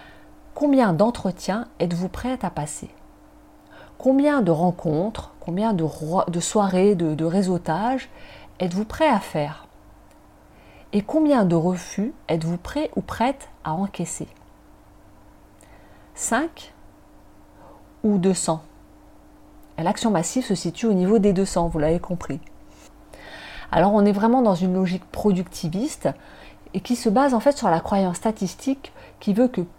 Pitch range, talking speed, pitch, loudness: 165-225 Hz, 130 wpm, 190 Hz, -22 LUFS